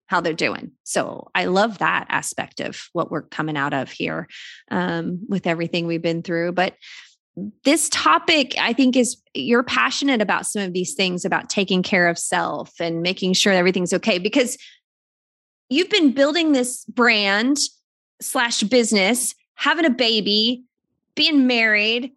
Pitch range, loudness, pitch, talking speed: 185-265 Hz, -19 LUFS, 225 Hz, 155 wpm